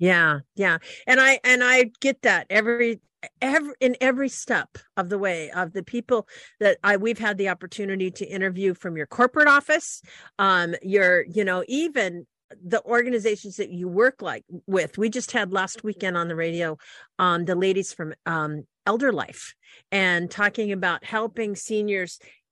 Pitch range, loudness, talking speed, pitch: 180-240 Hz, -23 LUFS, 170 wpm, 200 Hz